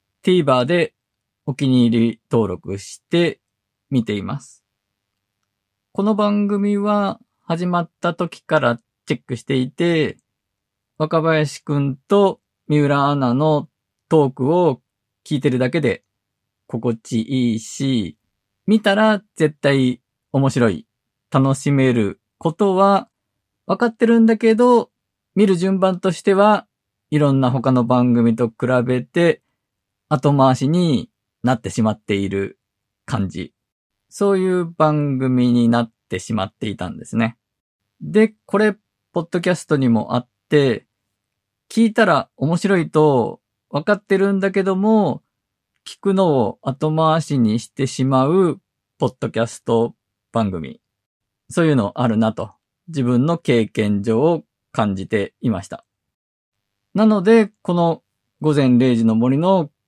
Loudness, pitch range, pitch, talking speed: -18 LUFS, 110-170 Hz, 130 Hz, 230 characters per minute